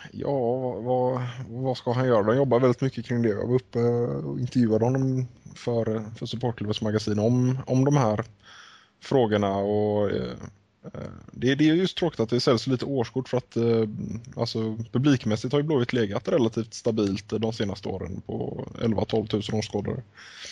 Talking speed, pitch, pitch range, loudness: 165 wpm, 120 Hz, 110-130 Hz, -26 LUFS